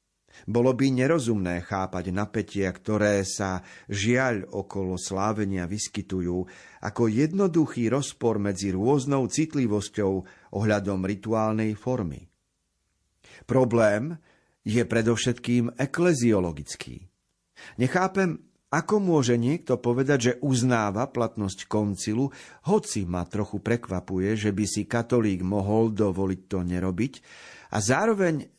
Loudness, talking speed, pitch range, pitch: -26 LUFS, 100 wpm, 95-130 Hz, 110 Hz